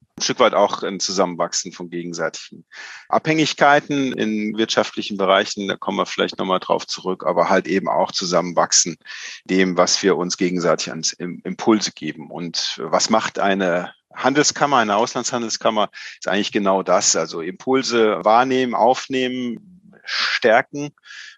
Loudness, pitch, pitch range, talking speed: -19 LUFS, 110 Hz, 95-130 Hz, 135 wpm